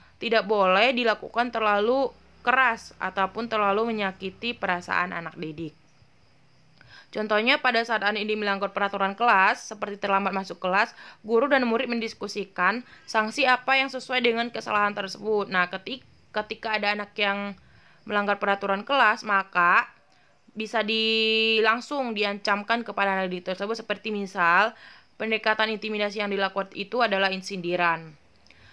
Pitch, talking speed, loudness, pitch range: 205 Hz, 125 wpm, -24 LUFS, 190-225 Hz